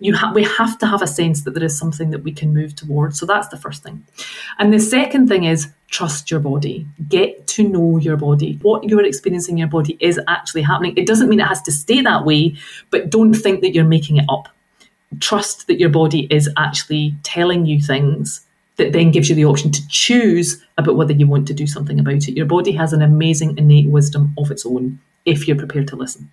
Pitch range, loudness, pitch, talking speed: 150-195 Hz, -15 LUFS, 160 Hz, 235 wpm